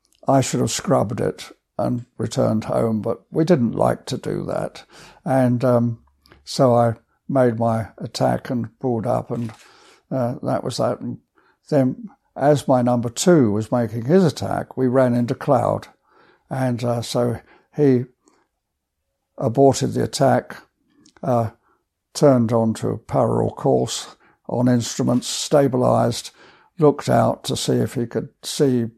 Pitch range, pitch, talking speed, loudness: 115-135 Hz, 125 Hz, 140 wpm, -20 LUFS